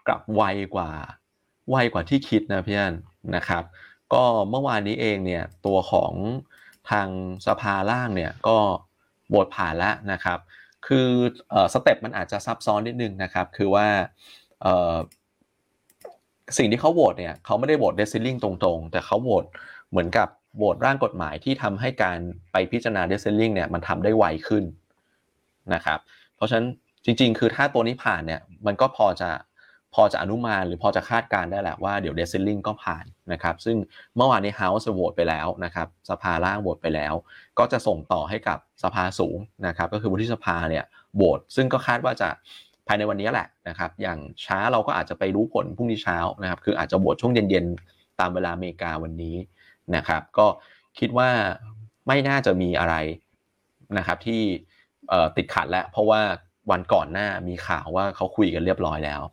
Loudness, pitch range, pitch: -24 LUFS, 90-110 Hz, 100 Hz